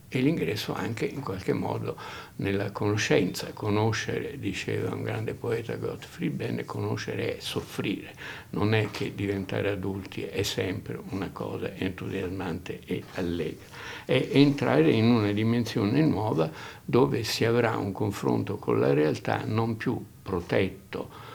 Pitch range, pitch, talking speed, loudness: 100-125 Hz, 110 Hz, 130 wpm, -28 LUFS